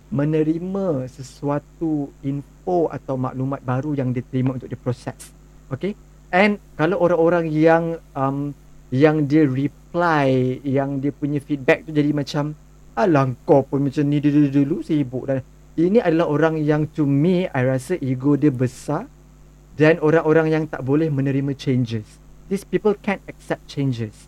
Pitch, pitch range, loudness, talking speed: 150 Hz, 135-160 Hz, -21 LUFS, 145 wpm